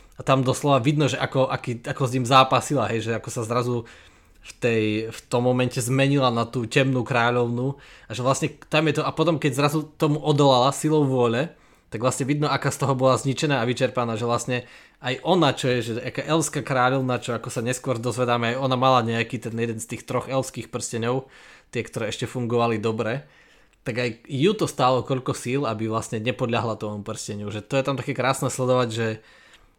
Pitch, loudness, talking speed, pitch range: 125 Hz, -23 LUFS, 205 wpm, 120-135 Hz